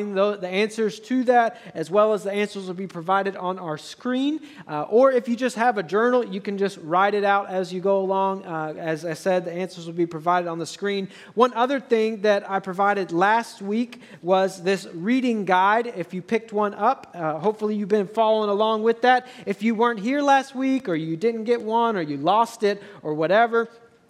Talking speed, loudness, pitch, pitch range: 215 wpm, -23 LUFS, 205 Hz, 185-230 Hz